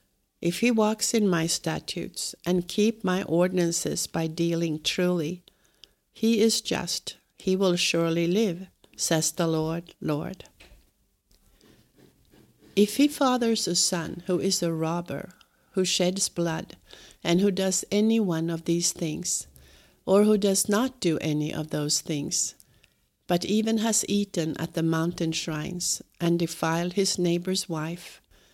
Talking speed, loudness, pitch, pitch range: 140 wpm, -26 LUFS, 175 Hz, 165-195 Hz